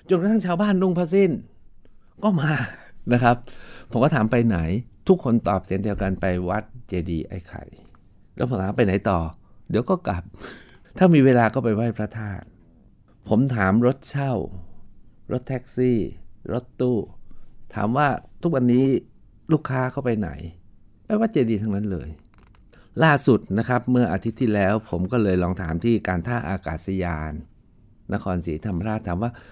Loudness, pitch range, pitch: -23 LUFS, 95-125 Hz, 110 Hz